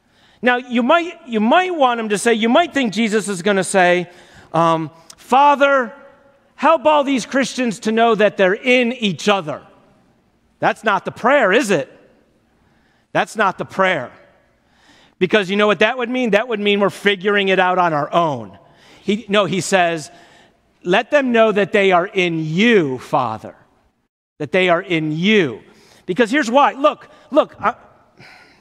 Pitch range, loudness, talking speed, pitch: 180-250 Hz, -16 LUFS, 170 wpm, 210 Hz